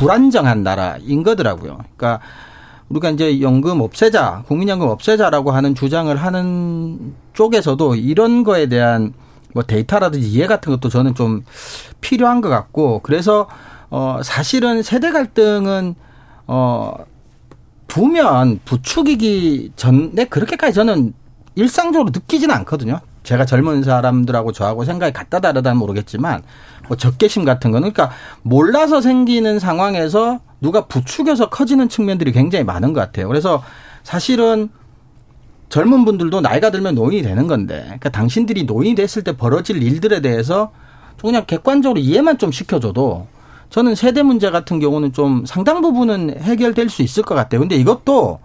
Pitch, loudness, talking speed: 160 Hz, -15 LUFS, 345 characters per minute